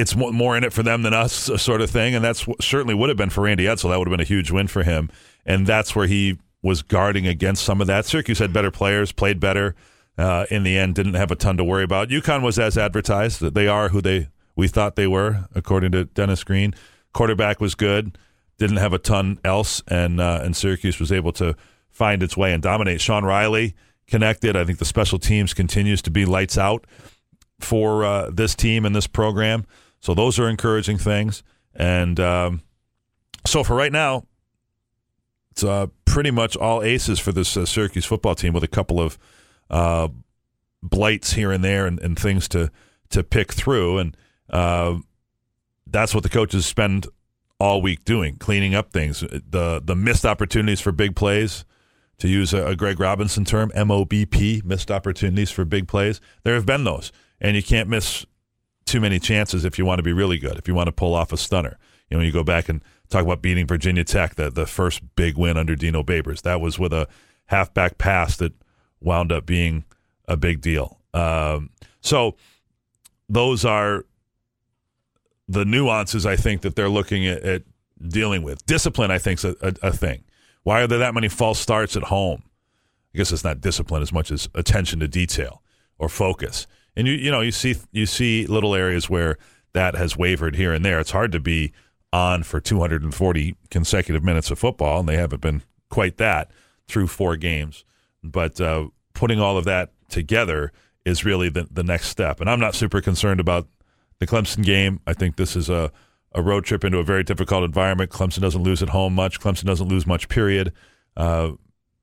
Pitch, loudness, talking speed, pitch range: 95 Hz, -21 LUFS, 200 wpm, 85-105 Hz